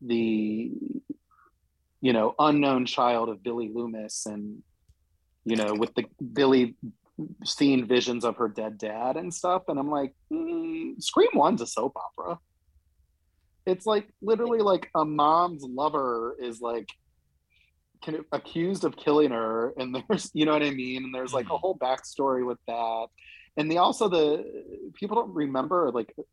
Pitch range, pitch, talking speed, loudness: 115-170 Hz, 130 Hz, 155 wpm, -27 LUFS